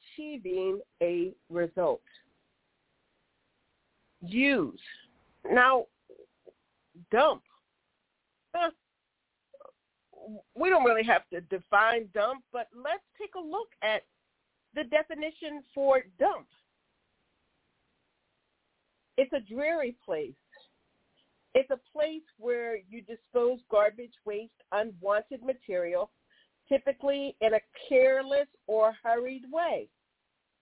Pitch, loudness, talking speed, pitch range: 265 Hz, -29 LUFS, 90 wpm, 220-310 Hz